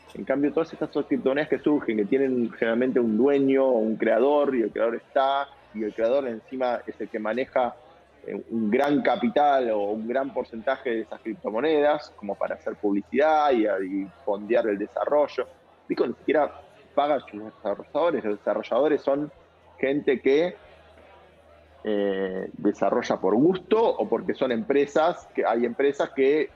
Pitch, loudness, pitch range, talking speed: 130 Hz, -25 LUFS, 110-145 Hz, 155 wpm